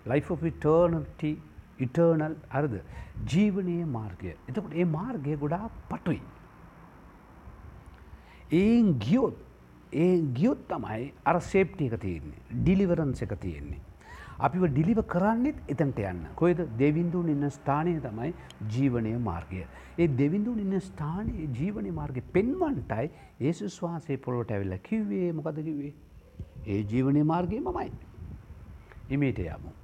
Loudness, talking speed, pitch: -29 LUFS, 95 wpm, 145 Hz